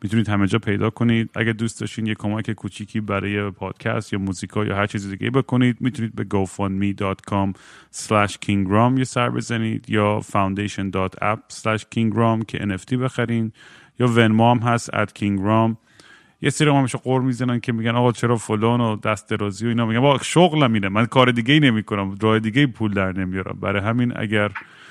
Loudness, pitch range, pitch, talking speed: -21 LUFS, 100-120 Hz, 110 Hz, 175 wpm